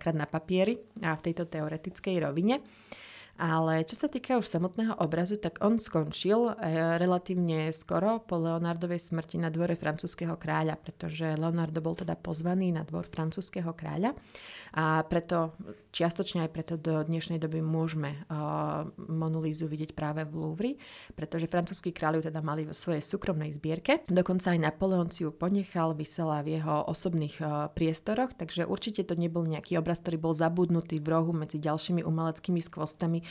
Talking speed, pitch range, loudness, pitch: 160 wpm, 160-180 Hz, -31 LUFS, 165 Hz